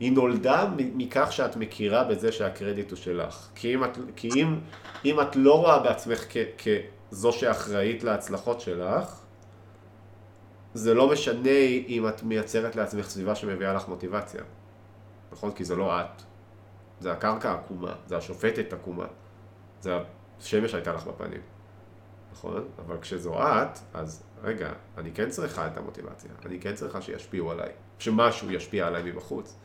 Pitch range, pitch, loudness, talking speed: 95-115 Hz, 105 Hz, -28 LUFS, 145 wpm